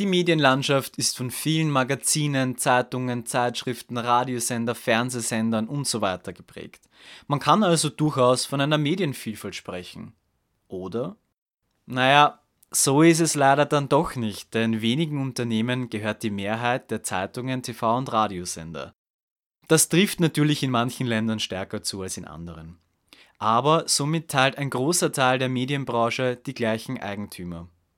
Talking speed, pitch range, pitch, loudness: 135 wpm, 110-140 Hz, 125 Hz, -23 LUFS